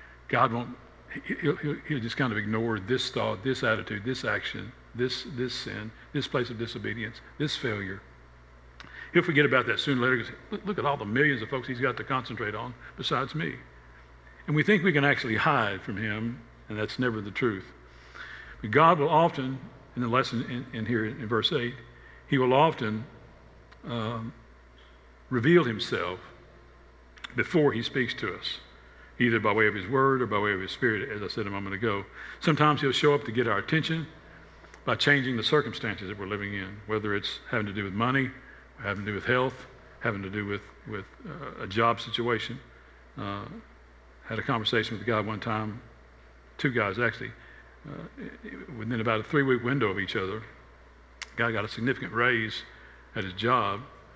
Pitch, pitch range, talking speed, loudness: 115 Hz, 100-130 Hz, 190 wpm, -28 LUFS